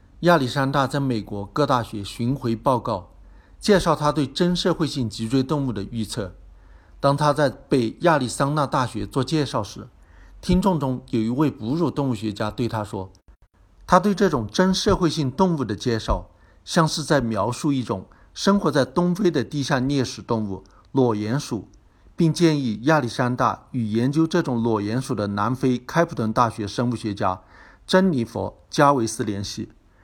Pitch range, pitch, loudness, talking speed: 105-150 Hz, 125 Hz, -22 LUFS, 255 characters per minute